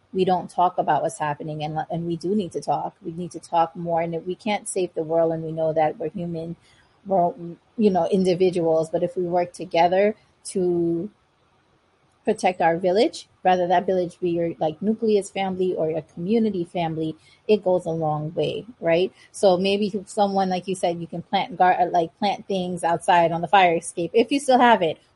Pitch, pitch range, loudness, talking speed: 175 Hz, 165-195 Hz, -23 LUFS, 205 wpm